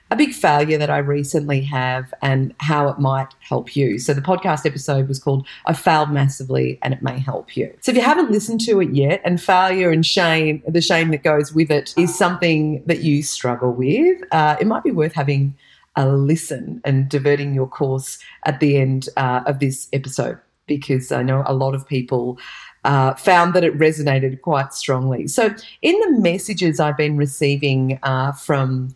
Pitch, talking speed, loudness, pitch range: 145 Hz, 190 wpm, -18 LUFS, 135-165 Hz